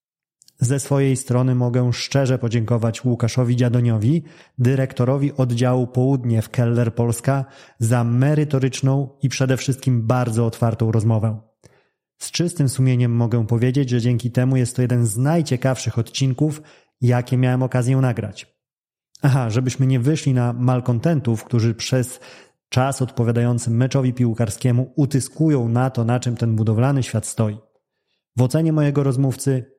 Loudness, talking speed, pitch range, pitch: -20 LUFS, 130 wpm, 120-135 Hz, 125 Hz